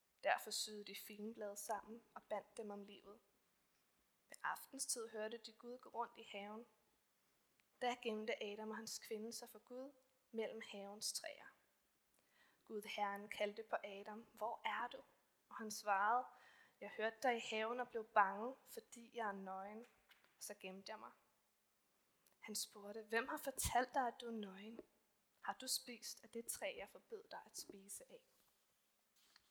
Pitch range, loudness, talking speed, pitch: 210-240 Hz, -46 LUFS, 165 wpm, 220 Hz